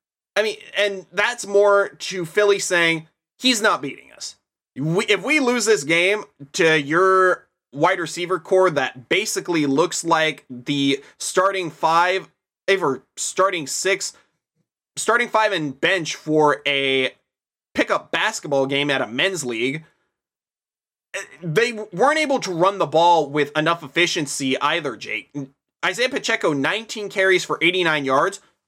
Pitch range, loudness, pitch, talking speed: 155-205 Hz, -20 LUFS, 180 Hz, 135 wpm